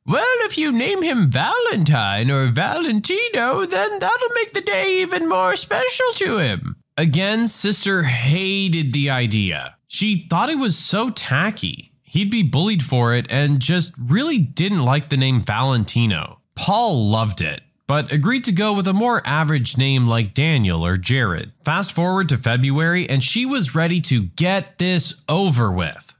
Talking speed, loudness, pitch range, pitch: 165 wpm, -18 LUFS, 130-210 Hz, 160 Hz